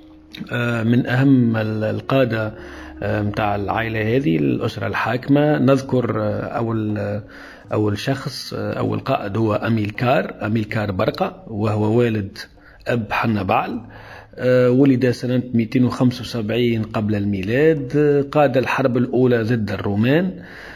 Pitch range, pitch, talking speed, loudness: 105-130 Hz, 115 Hz, 95 wpm, -19 LUFS